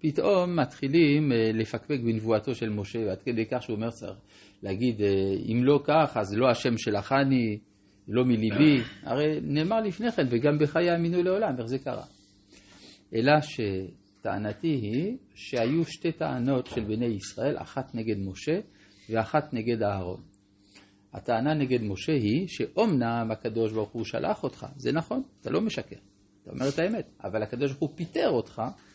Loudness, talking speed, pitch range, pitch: -28 LUFS, 155 wpm, 105-150 Hz, 120 Hz